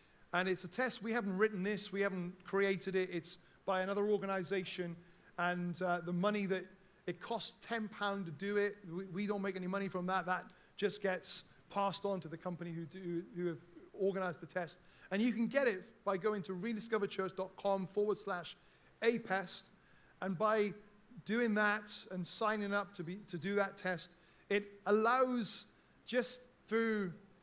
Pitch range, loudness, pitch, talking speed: 180-210 Hz, -38 LUFS, 195 Hz, 175 wpm